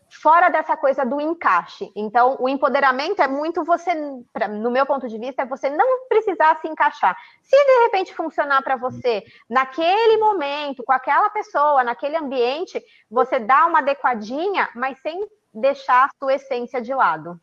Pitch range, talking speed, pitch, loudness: 265-345 Hz, 160 wpm, 285 Hz, -19 LUFS